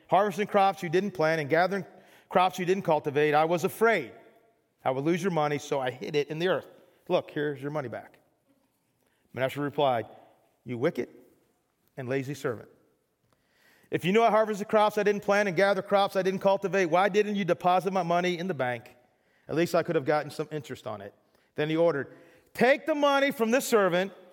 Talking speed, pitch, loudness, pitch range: 200 wpm, 180 Hz, -27 LUFS, 150-200 Hz